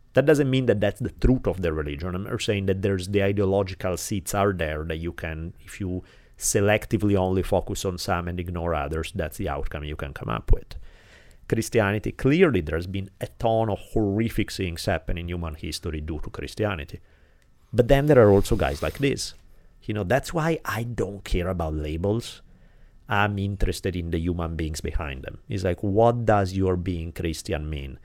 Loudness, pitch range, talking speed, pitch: -25 LUFS, 85-105 Hz, 190 wpm, 95 Hz